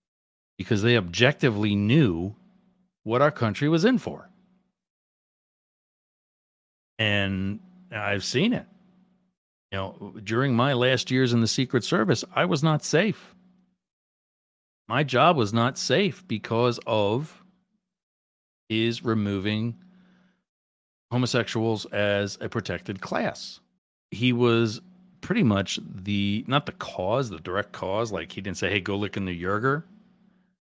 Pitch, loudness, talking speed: 115 Hz, -25 LUFS, 125 wpm